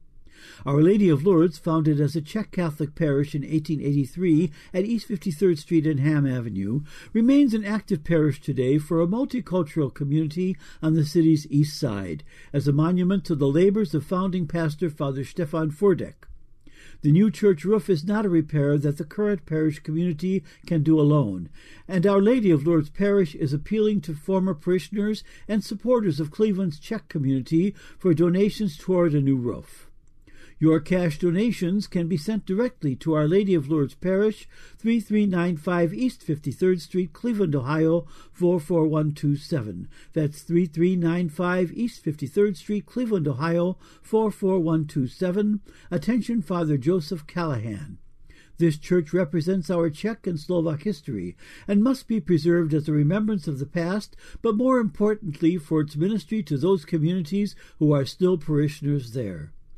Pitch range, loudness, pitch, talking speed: 155-195 Hz, -24 LUFS, 170 Hz, 150 wpm